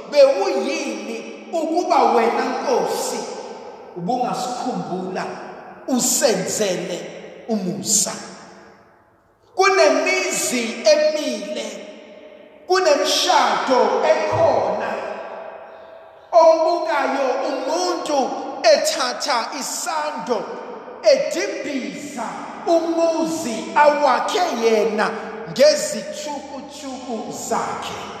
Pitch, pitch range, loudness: 290 Hz, 245-325 Hz, -19 LUFS